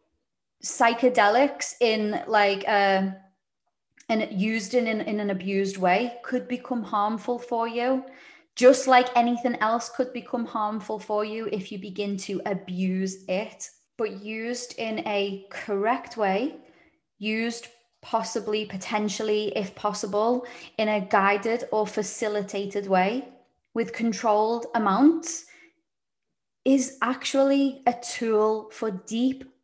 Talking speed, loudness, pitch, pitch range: 115 wpm, -25 LUFS, 220 Hz, 205-245 Hz